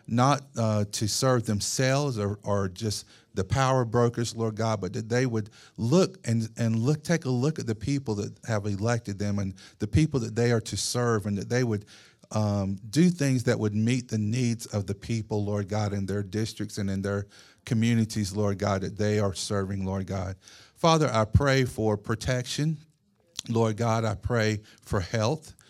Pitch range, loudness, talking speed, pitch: 105-120 Hz, -27 LUFS, 190 wpm, 110 Hz